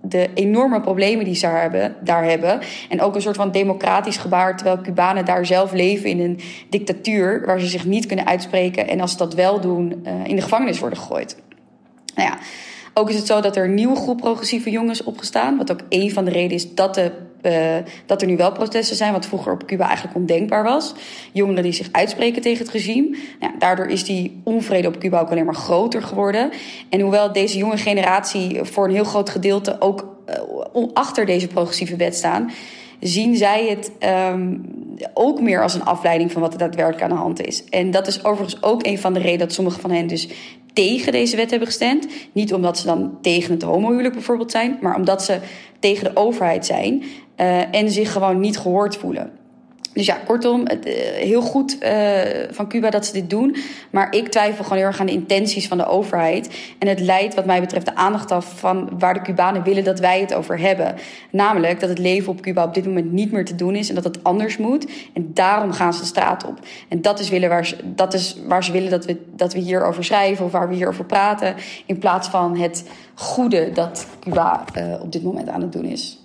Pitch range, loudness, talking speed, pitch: 180-215 Hz, -19 LUFS, 220 wpm, 195 Hz